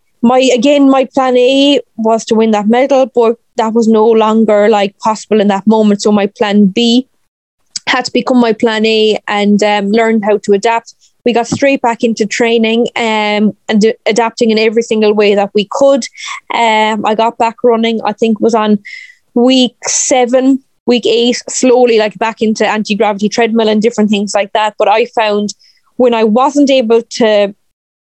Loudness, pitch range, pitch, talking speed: -10 LUFS, 215-245 Hz, 225 Hz, 185 wpm